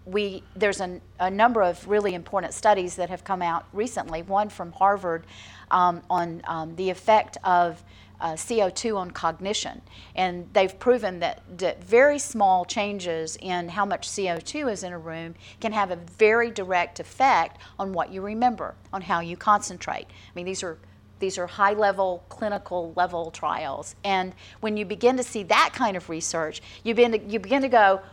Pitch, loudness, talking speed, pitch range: 190 Hz, -25 LUFS, 180 wpm, 175-210 Hz